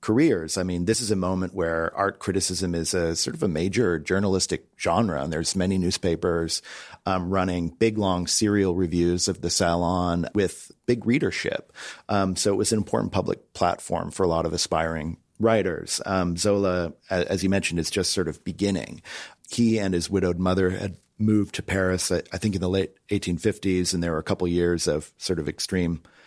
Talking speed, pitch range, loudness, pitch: 190 wpm, 85-100 Hz, -25 LUFS, 90 Hz